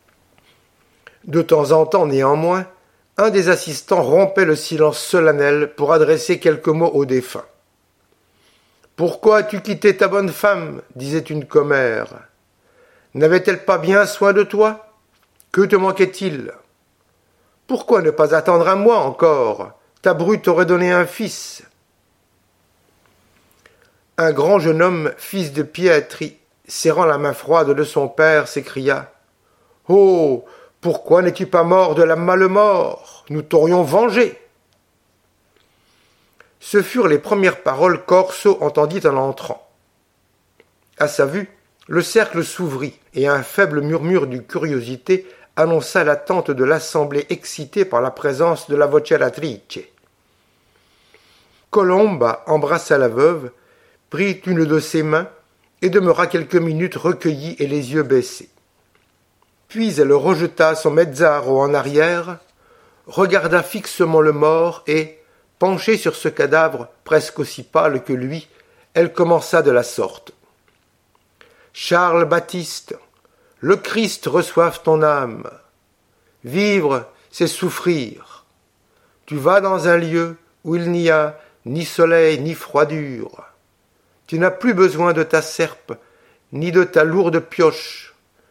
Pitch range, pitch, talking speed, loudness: 150-195 Hz, 170 Hz, 125 wpm, -16 LUFS